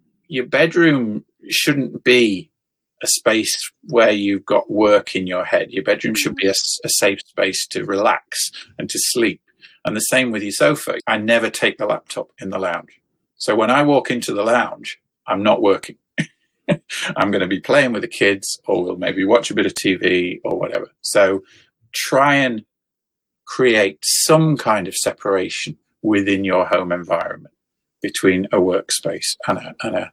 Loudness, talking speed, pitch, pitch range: -18 LUFS, 175 wpm, 105 Hz, 95-130 Hz